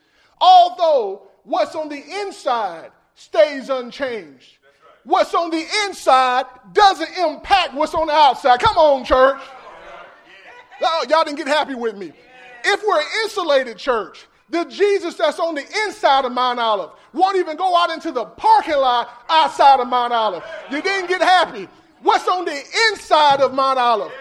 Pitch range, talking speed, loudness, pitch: 270-365 Hz, 160 wpm, -17 LUFS, 320 Hz